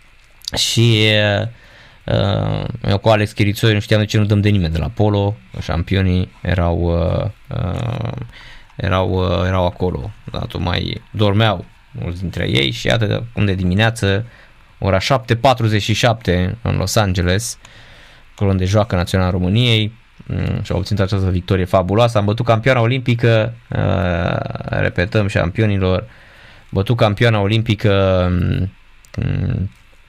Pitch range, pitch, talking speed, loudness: 95-115 Hz, 105 Hz, 135 wpm, -17 LUFS